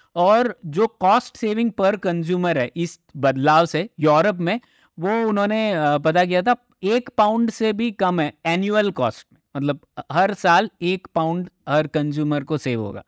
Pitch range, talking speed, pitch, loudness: 150-215 Hz, 165 wpm, 175 Hz, -20 LUFS